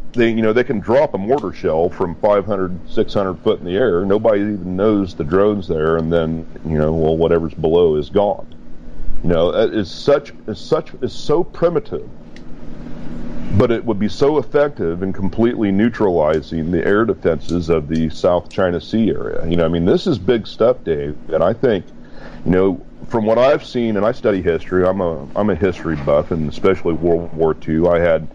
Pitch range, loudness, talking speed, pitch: 80-100 Hz, -17 LUFS, 200 wpm, 85 Hz